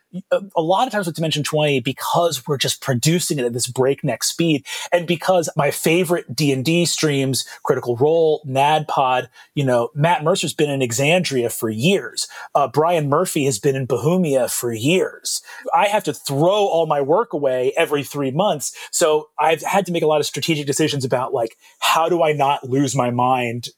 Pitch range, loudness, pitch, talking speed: 135-170 Hz, -19 LUFS, 150 Hz, 185 wpm